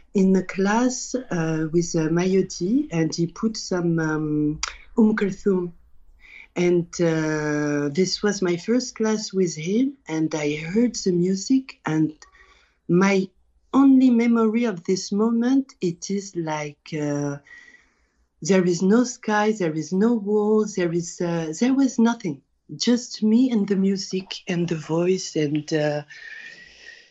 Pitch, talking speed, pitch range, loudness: 190 Hz, 140 wpm, 165-230 Hz, -22 LUFS